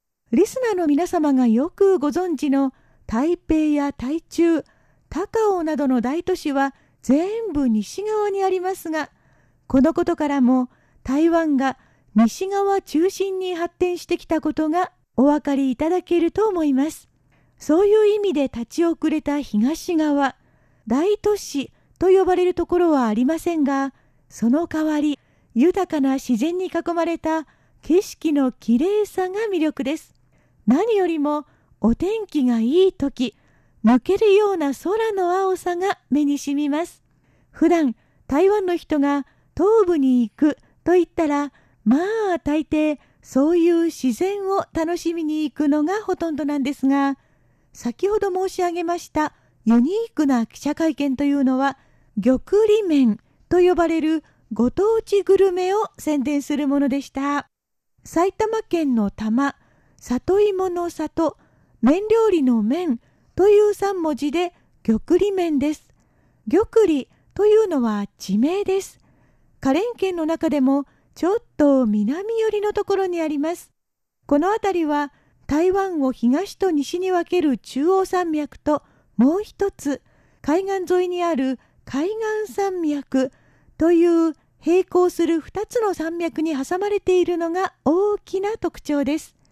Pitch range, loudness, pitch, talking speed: 280-370 Hz, -21 LUFS, 320 Hz, 250 characters per minute